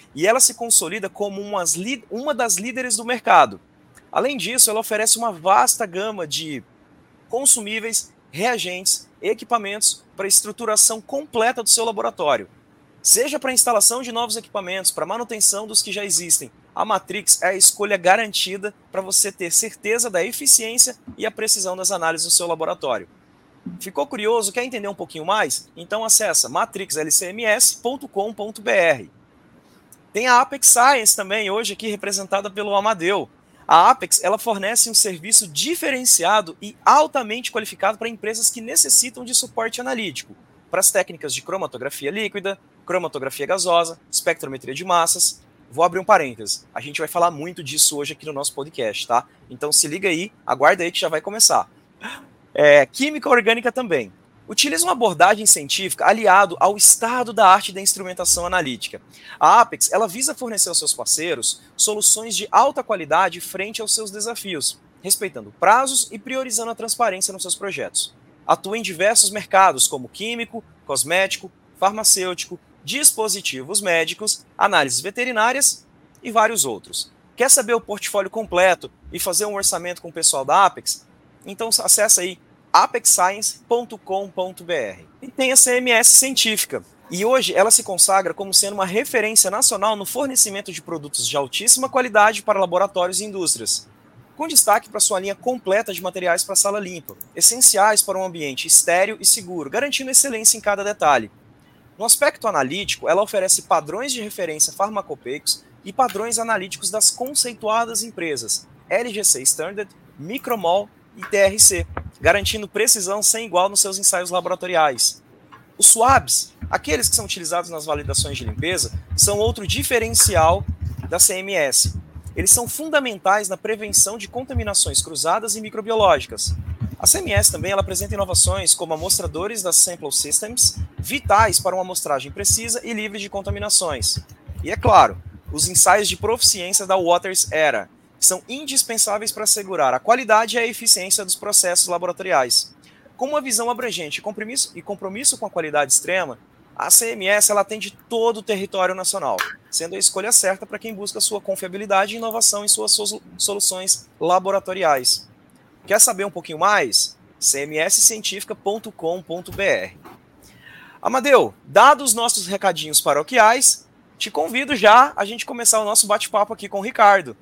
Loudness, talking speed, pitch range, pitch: -17 LUFS, 150 wpm, 180-230 Hz, 205 Hz